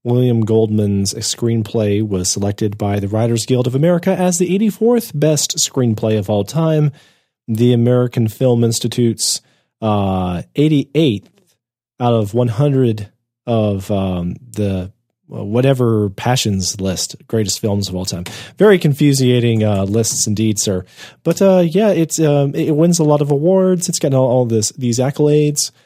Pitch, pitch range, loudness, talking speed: 120 Hz, 105-150 Hz, -15 LUFS, 155 wpm